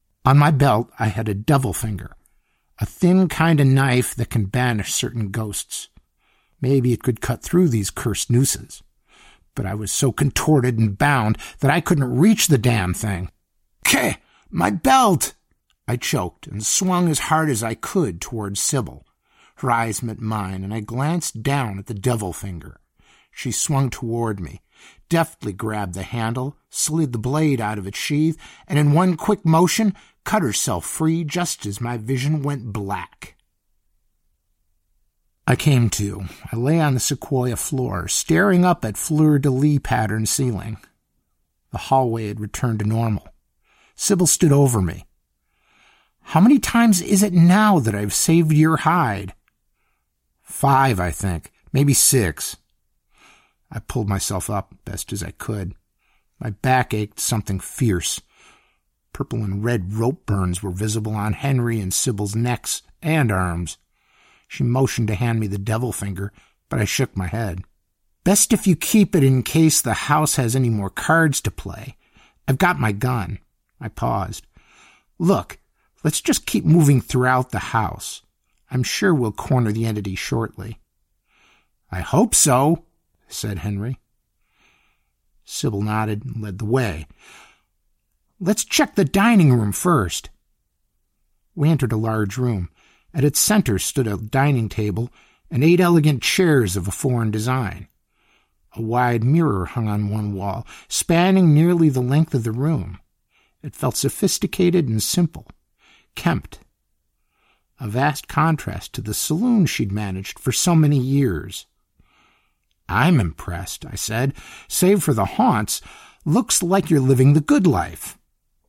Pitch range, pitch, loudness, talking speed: 105-150 Hz, 120 Hz, -20 LUFS, 150 wpm